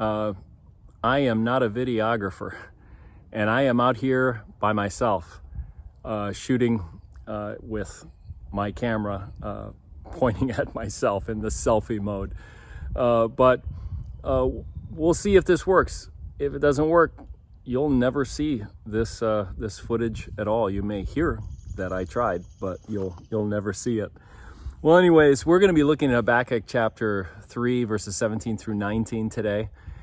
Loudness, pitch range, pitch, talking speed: -24 LUFS, 95-120 Hz, 110 Hz, 150 wpm